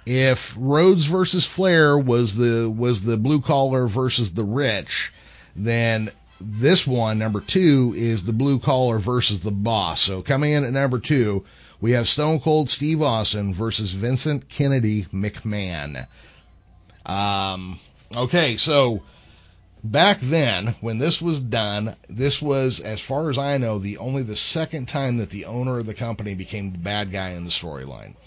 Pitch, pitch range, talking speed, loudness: 115 Hz, 105-140 Hz, 160 wpm, -20 LUFS